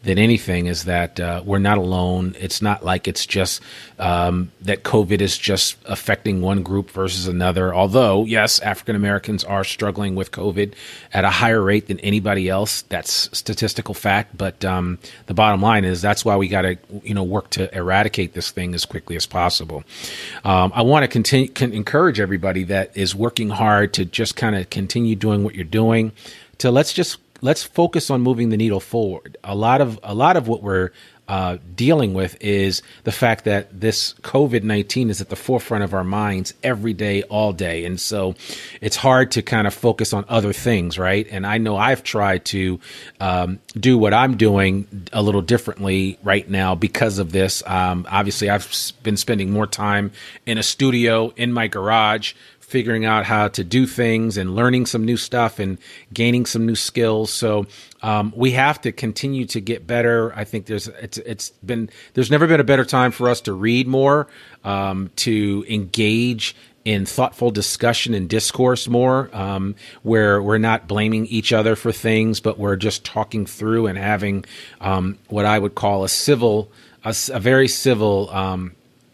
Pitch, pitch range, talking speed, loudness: 105 Hz, 95-115 Hz, 185 wpm, -19 LUFS